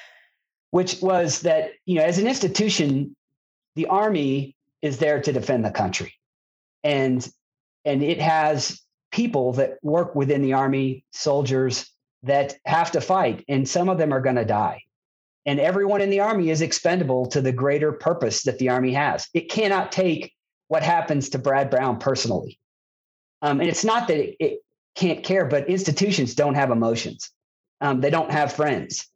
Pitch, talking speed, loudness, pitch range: 150 Hz, 170 wpm, -22 LUFS, 135-180 Hz